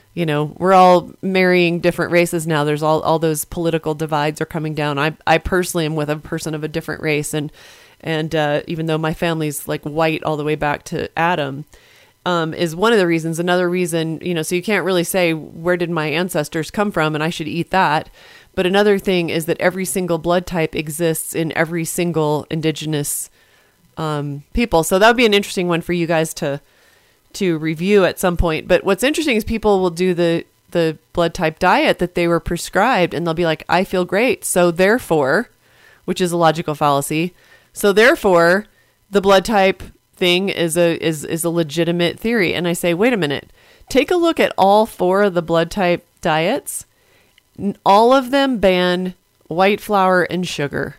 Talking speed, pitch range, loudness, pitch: 200 wpm, 160-185 Hz, -17 LUFS, 170 Hz